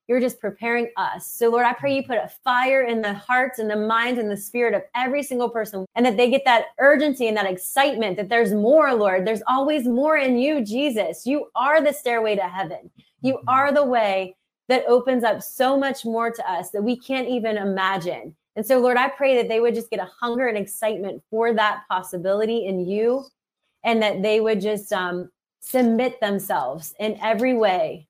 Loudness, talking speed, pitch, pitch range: -21 LUFS, 205 wpm, 230 Hz, 210-255 Hz